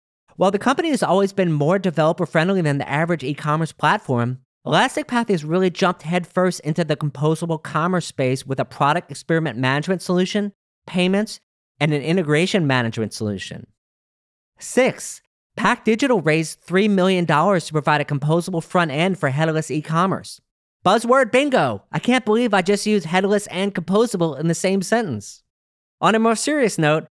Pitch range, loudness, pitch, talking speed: 150-195 Hz, -20 LUFS, 170 Hz, 165 wpm